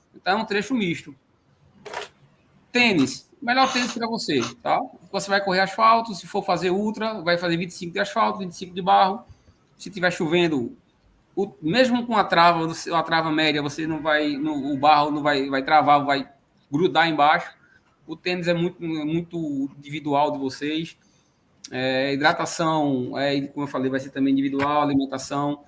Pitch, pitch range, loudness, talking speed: 165 Hz, 145-195 Hz, -22 LUFS, 160 wpm